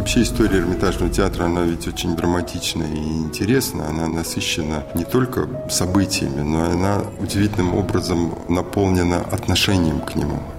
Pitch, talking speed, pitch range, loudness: 85 Hz, 130 wpm, 80-100 Hz, -20 LUFS